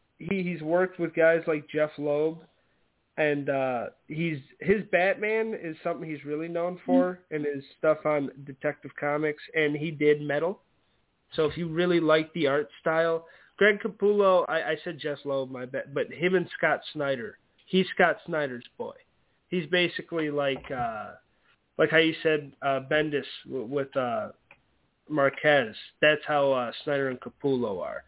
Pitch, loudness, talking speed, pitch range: 155 Hz, -27 LUFS, 160 wpm, 145-175 Hz